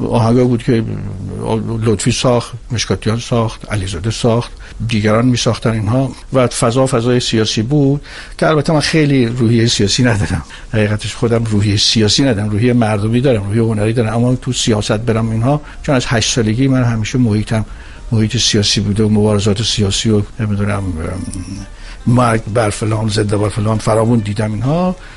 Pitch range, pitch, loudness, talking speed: 105-125 Hz, 115 Hz, -14 LUFS, 155 wpm